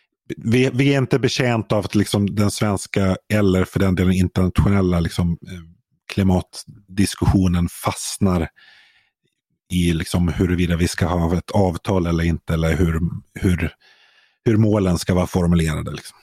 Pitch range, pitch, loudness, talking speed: 85-105 Hz, 95 Hz, -20 LUFS, 135 wpm